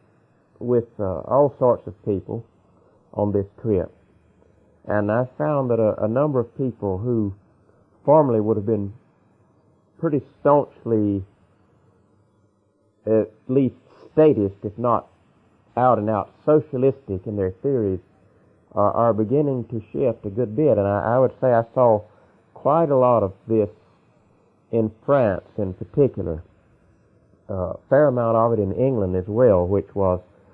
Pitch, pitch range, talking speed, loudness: 110 Hz, 100-125 Hz, 145 wpm, -21 LUFS